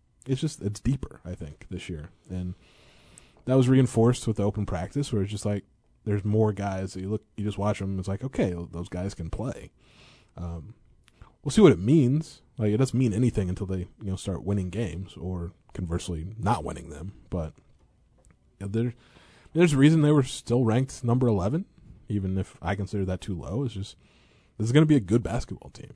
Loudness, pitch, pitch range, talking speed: -27 LUFS, 105 Hz, 90-120 Hz, 215 wpm